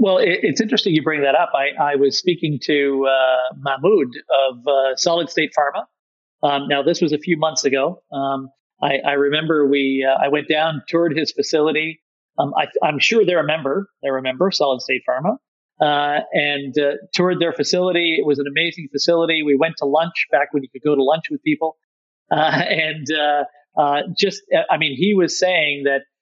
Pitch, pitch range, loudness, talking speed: 150 Hz, 140-165 Hz, -18 LUFS, 200 wpm